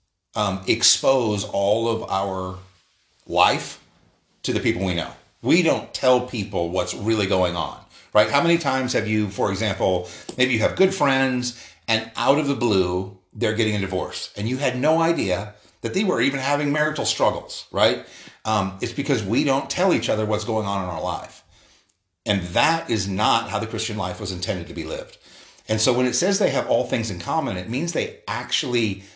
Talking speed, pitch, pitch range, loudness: 200 wpm, 110 Hz, 95-125 Hz, -22 LUFS